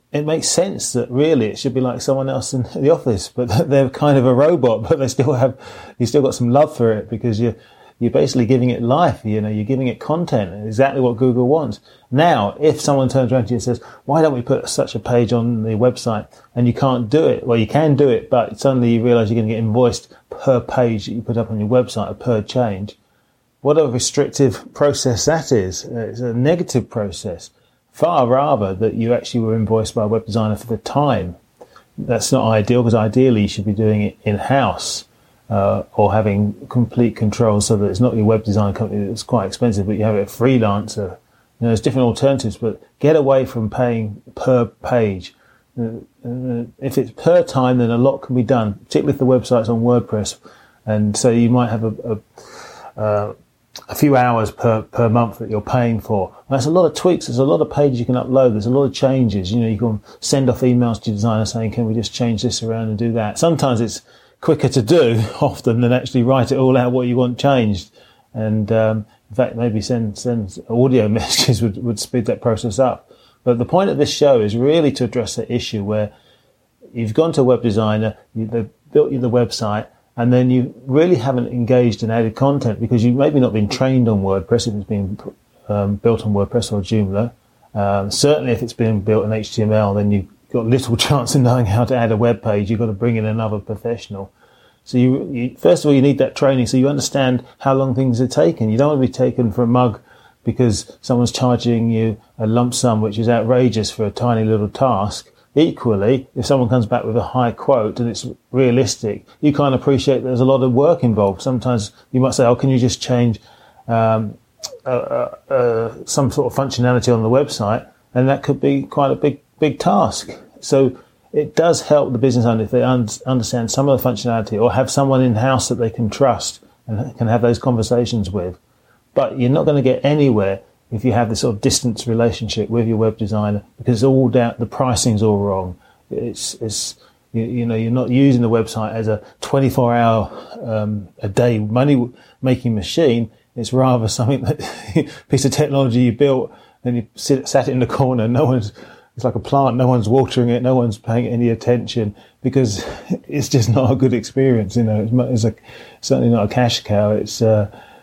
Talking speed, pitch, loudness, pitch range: 215 wpm, 120 Hz, -17 LUFS, 110-130 Hz